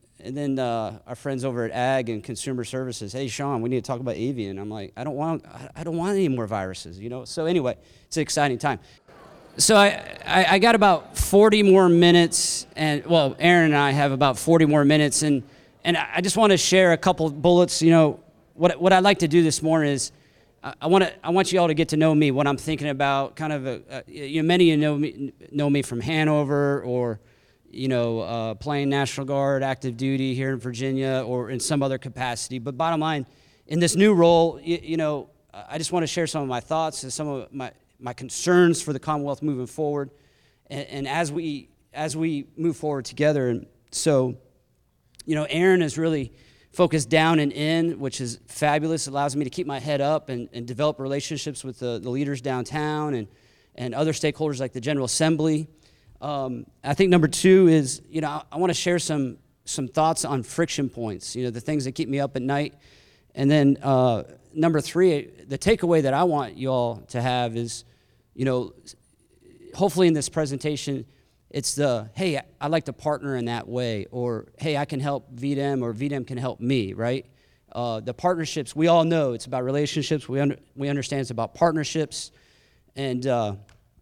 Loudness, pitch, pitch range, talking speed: -23 LUFS, 145 Hz, 130-160 Hz, 210 wpm